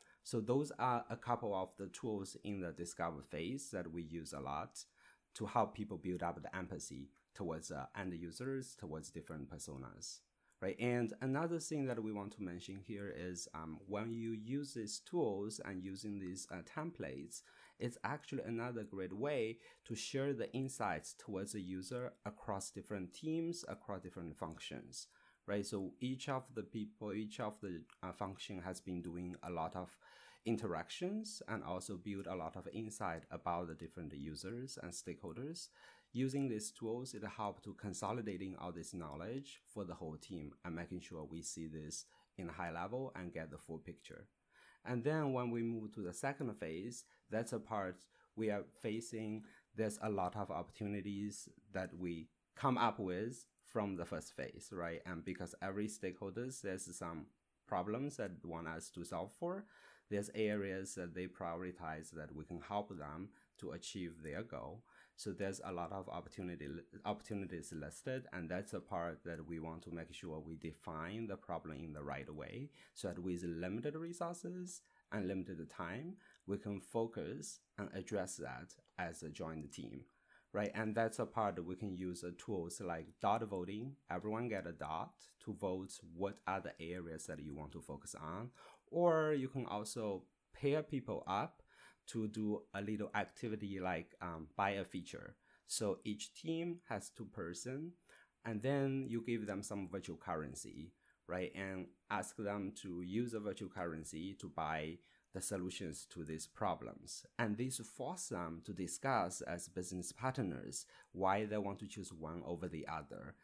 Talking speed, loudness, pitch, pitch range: 170 wpm, -44 LUFS, 95 Hz, 85-115 Hz